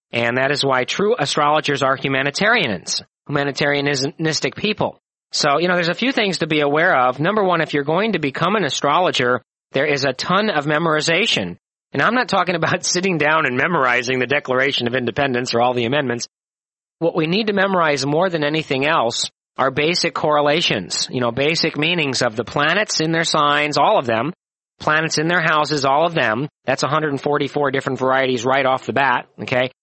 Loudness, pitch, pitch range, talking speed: -18 LUFS, 145 Hz, 135-165 Hz, 190 wpm